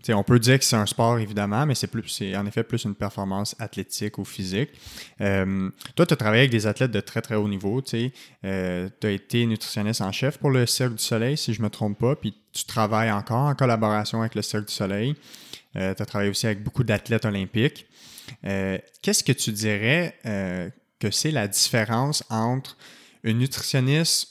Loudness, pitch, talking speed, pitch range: -24 LUFS, 110 Hz, 210 wpm, 100-130 Hz